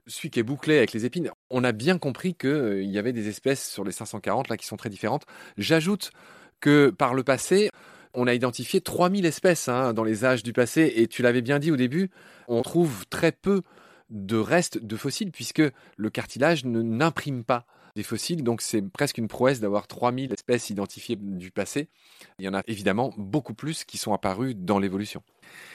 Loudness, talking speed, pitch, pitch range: -26 LUFS, 200 wpm, 125 Hz, 110-145 Hz